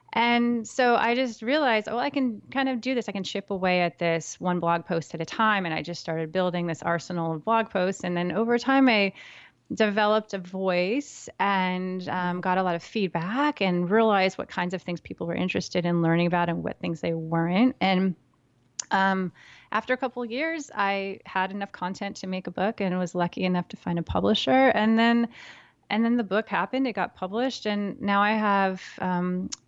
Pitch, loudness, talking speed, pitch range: 190 Hz, -26 LUFS, 210 wpm, 175-225 Hz